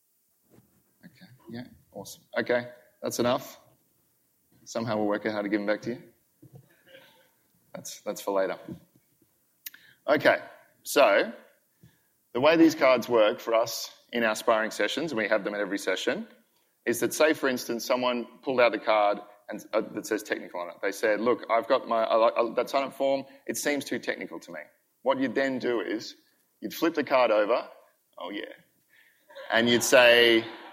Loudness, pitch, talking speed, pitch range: -26 LUFS, 120 Hz, 175 wpm, 115-135 Hz